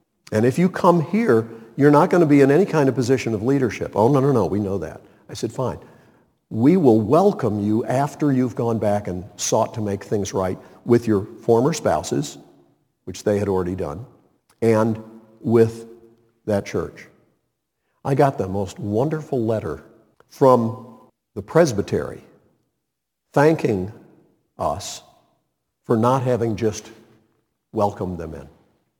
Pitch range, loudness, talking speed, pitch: 105-135 Hz, -20 LUFS, 150 wpm, 115 Hz